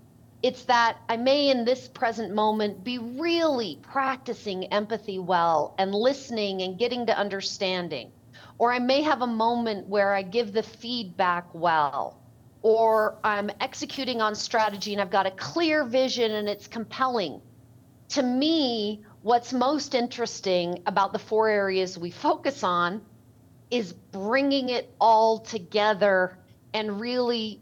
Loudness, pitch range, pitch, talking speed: -26 LUFS, 195-245 Hz, 220 Hz, 140 wpm